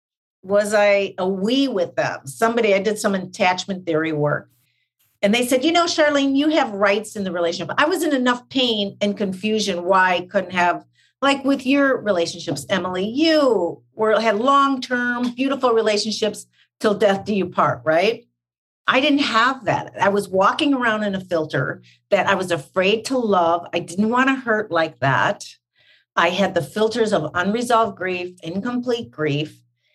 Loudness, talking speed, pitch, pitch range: -20 LUFS, 175 wpm, 205 Hz, 175-245 Hz